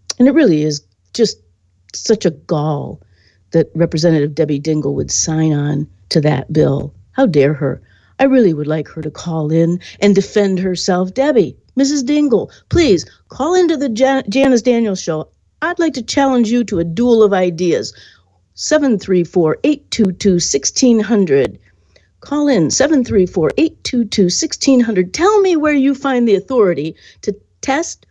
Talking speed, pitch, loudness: 140 wpm, 190 Hz, -15 LUFS